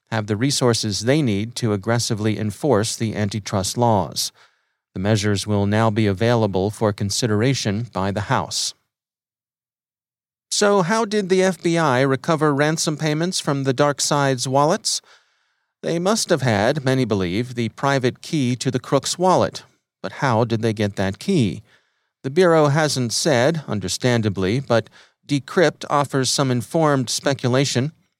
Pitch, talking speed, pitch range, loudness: 125 Hz, 140 wpm, 110-145 Hz, -20 LUFS